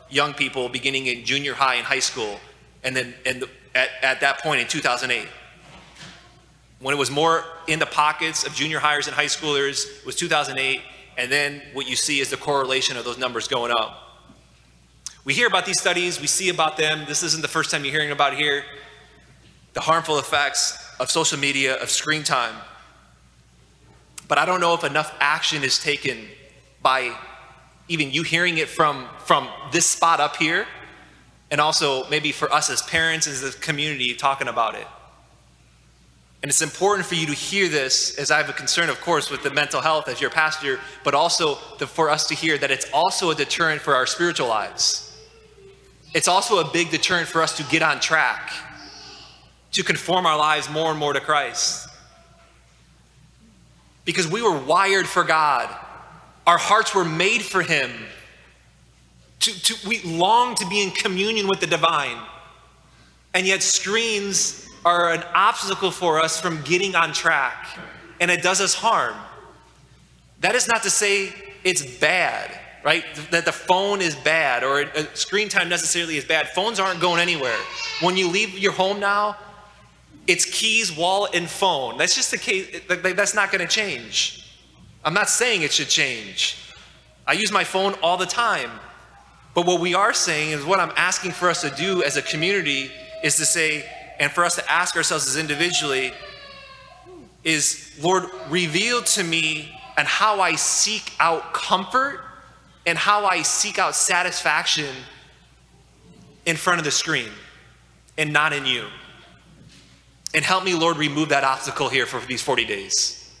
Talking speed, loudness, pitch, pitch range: 170 wpm, -20 LUFS, 160 Hz, 145-185 Hz